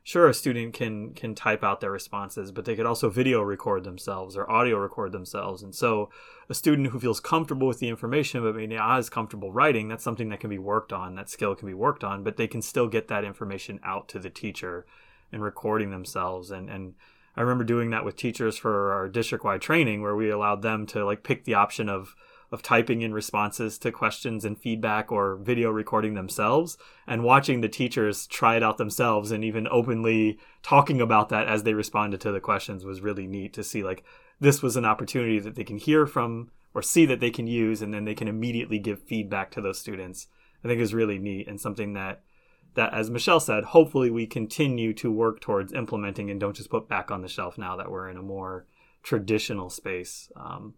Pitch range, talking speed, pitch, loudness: 100-120 Hz, 220 wpm, 110 Hz, -26 LUFS